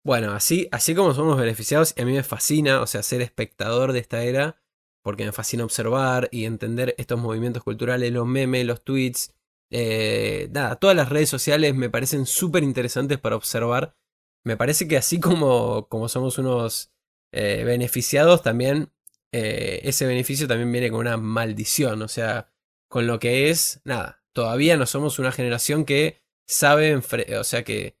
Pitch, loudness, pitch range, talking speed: 125 Hz, -22 LUFS, 115-145 Hz, 170 wpm